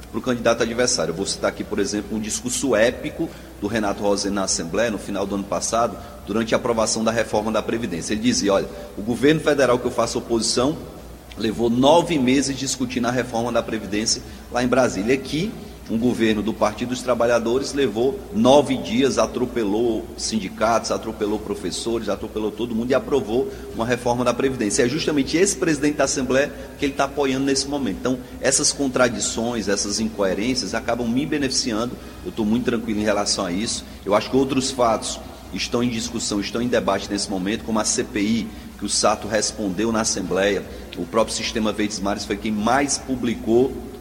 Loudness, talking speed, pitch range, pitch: -21 LUFS, 185 wpm, 105-125 Hz, 115 Hz